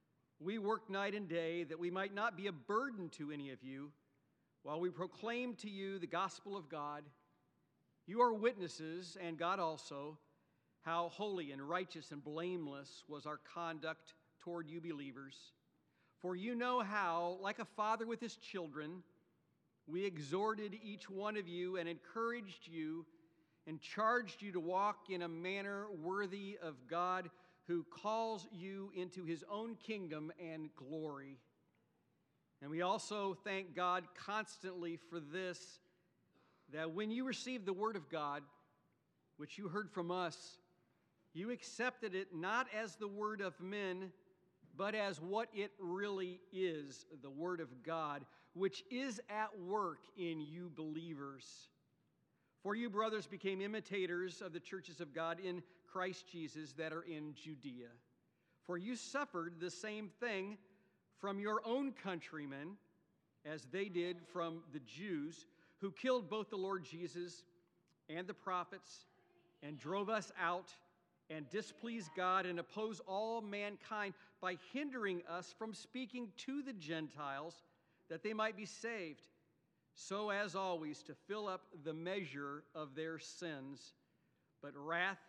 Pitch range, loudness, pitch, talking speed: 160-200 Hz, -44 LUFS, 180 Hz, 145 wpm